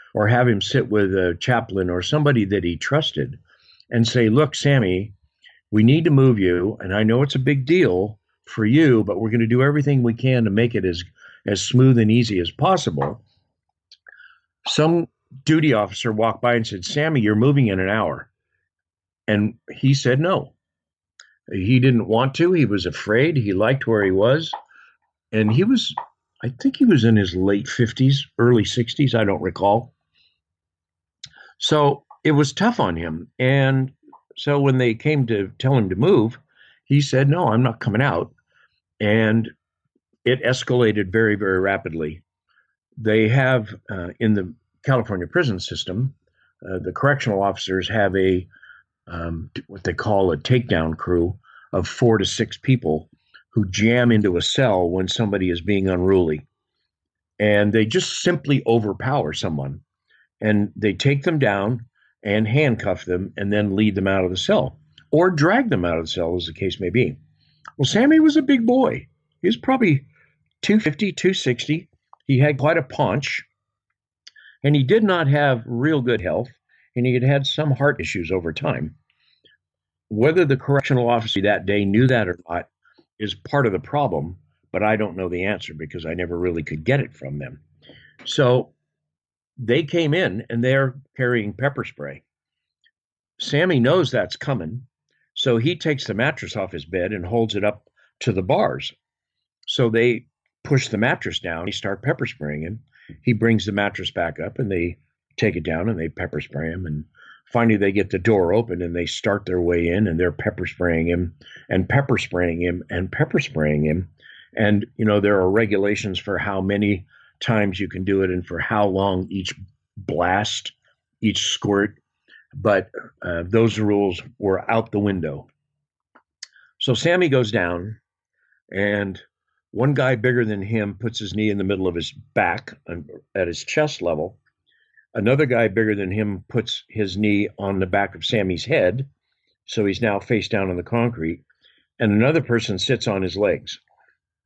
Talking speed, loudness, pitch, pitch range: 175 wpm, -20 LUFS, 110 Hz, 95-130 Hz